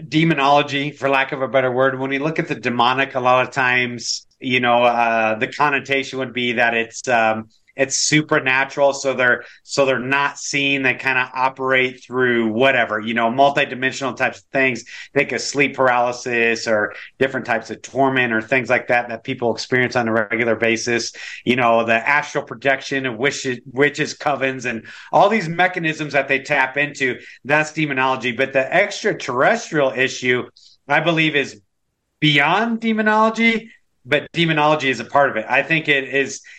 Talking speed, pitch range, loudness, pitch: 175 wpm, 120-145 Hz, -18 LUFS, 135 Hz